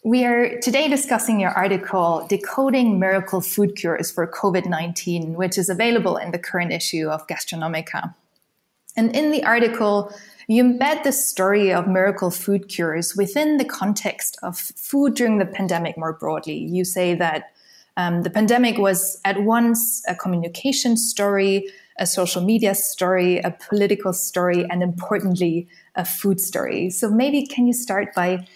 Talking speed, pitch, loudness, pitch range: 155 wpm, 195 Hz, -20 LUFS, 180-230 Hz